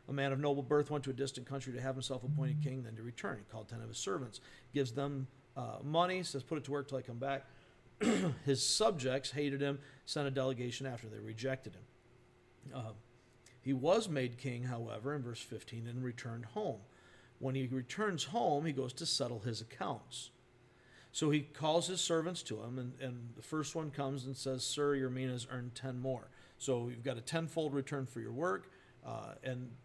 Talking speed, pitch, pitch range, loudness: 205 wpm, 130 Hz, 125-140 Hz, -39 LUFS